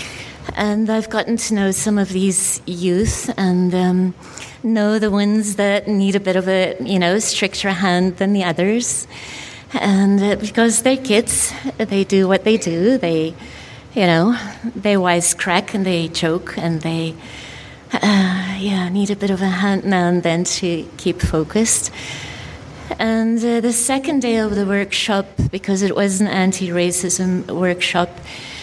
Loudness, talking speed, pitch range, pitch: -17 LUFS, 155 wpm, 180-215 Hz, 195 Hz